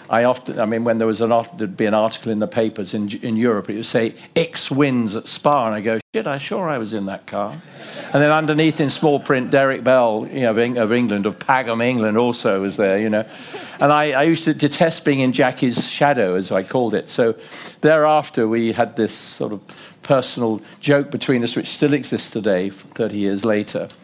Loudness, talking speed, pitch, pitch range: -19 LUFS, 220 wpm, 120 Hz, 110-145 Hz